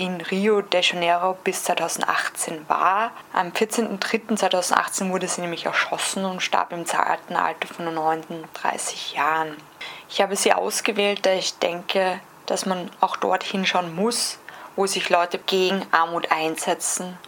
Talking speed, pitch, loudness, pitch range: 140 wpm, 185 Hz, -23 LUFS, 175-195 Hz